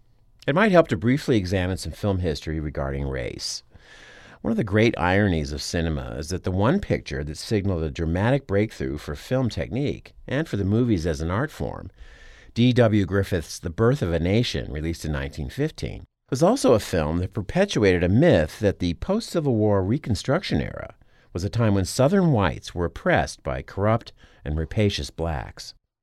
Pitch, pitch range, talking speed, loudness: 100 Hz, 80-115 Hz, 180 wpm, -24 LUFS